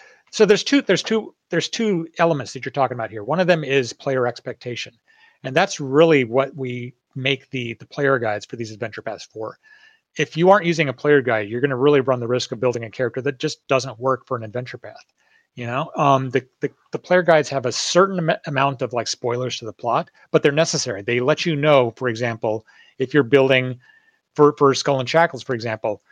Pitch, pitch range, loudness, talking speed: 135 Hz, 125-160 Hz, -20 LUFS, 225 wpm